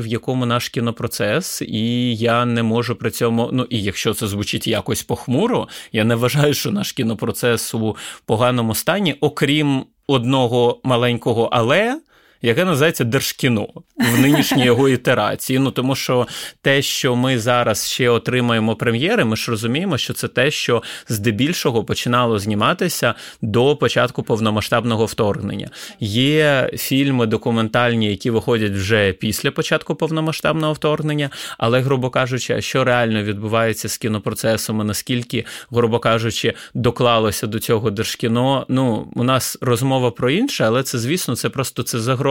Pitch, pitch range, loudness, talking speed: 120 Hz, 115-135 Hz, -18 LUFS, 140 wpm